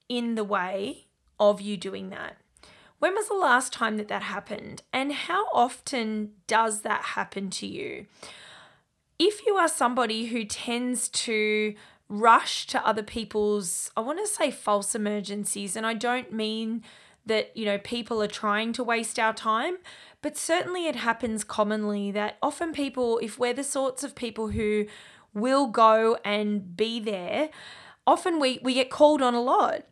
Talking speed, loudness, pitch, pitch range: 165 wpm, -26 LUFS, 230 Hz, 210-260 Hz